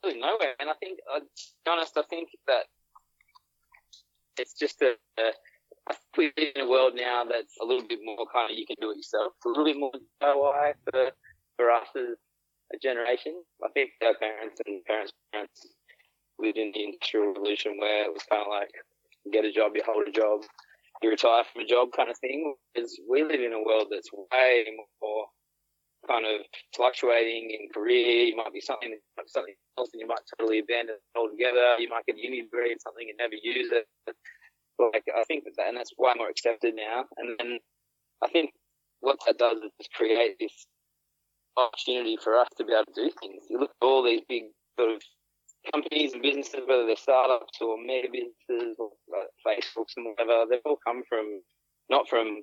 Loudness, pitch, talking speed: -28 LUFS, 140 Hz, 200 wpm